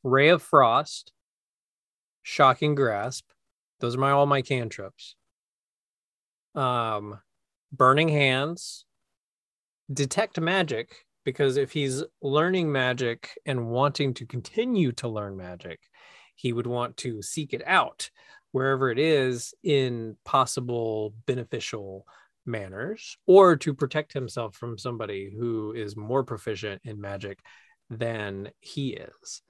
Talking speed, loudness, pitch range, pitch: 115 wpm, -26 LUFS, 110-145 Hz, 125 Hz